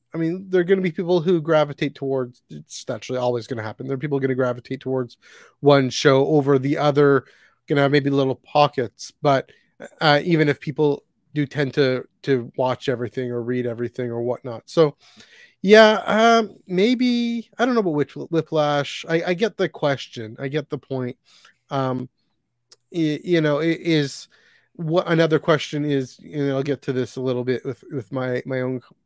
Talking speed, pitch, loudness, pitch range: 200 wpm, 145 Hz, -21 LUFS, 130-165 Hz